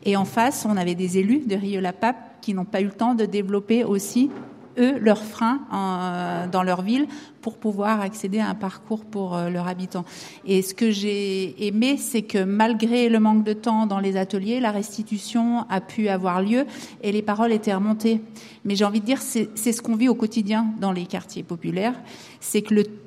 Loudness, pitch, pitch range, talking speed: -23 LUFS, 215 Hz, 195-230 Hz, 205 wpm